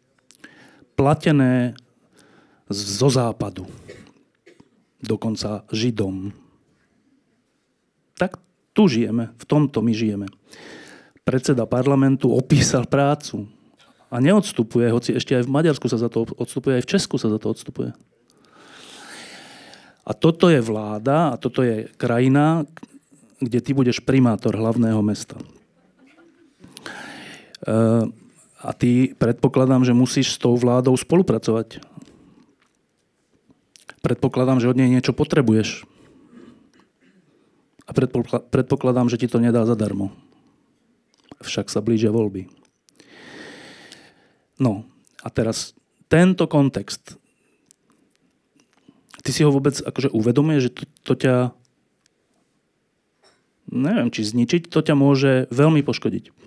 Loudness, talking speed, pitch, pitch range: -20 LUFS, 105 wpm, 125 Hz, 115-145 Hz